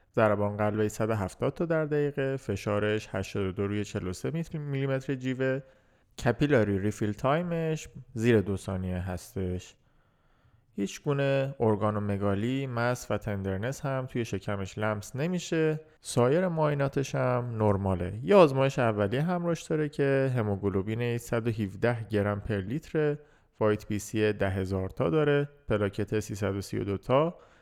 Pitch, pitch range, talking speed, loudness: 115 Hz, 105-140 Hz, 125 wpm, -29 LUFS